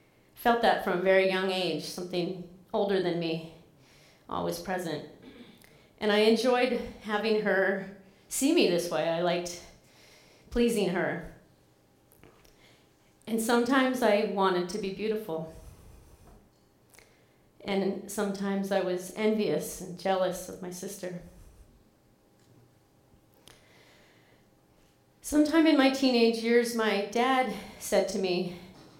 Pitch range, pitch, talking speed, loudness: 175-220 Hz, 195 Hz, 110 wpm, -28 LUFS